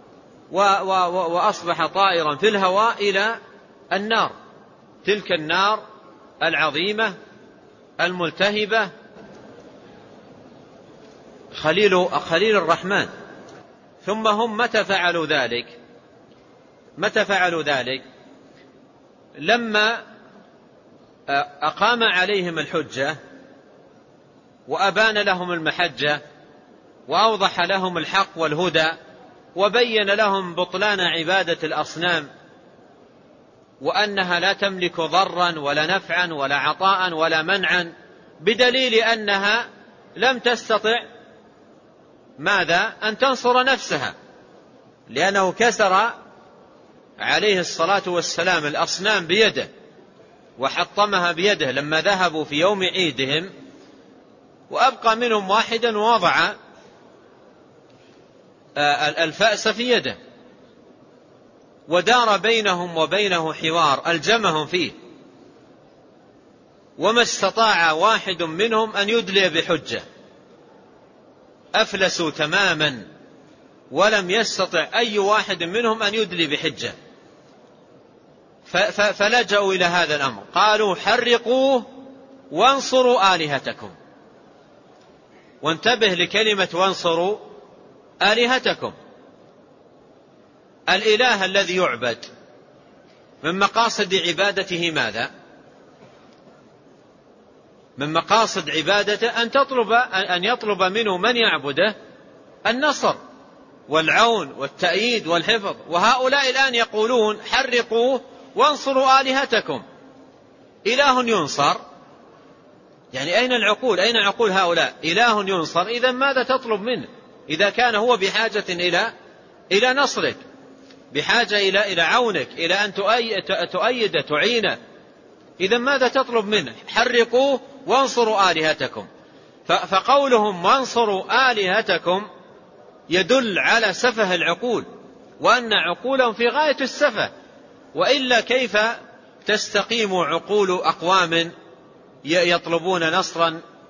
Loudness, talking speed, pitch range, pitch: -19 LUFS, 80 wpm, 175-230 Hz, 200 Hz